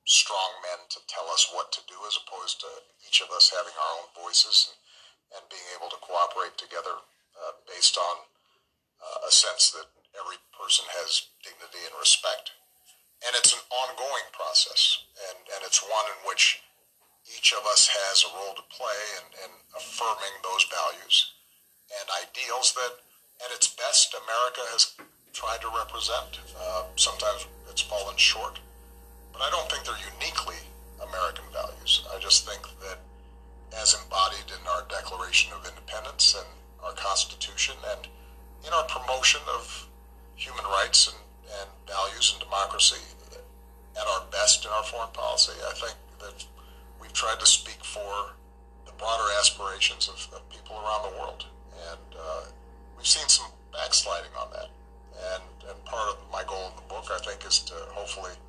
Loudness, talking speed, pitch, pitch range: -24 LUFS, 160 wpm, 65 Hz, 65-70 Hz